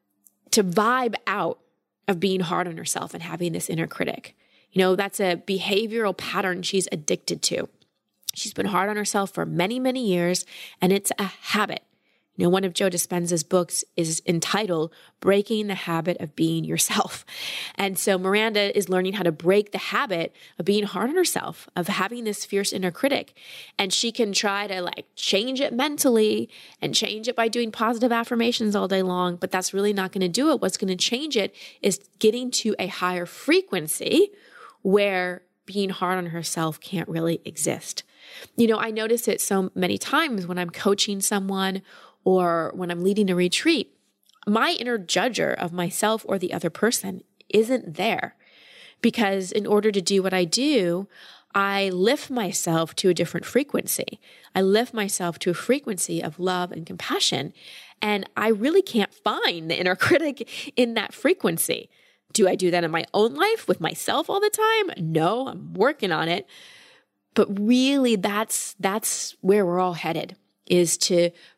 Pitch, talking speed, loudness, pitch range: 195 Hz, 175 wpm, -24 LUFS, 180-225 Hz